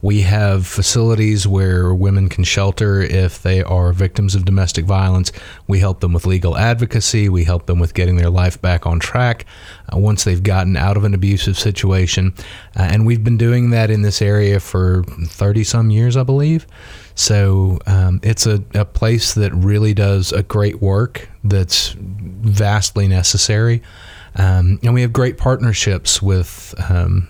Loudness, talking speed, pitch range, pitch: -15 LUFS, 165 wpm, 95-105 Hz, 100 Hz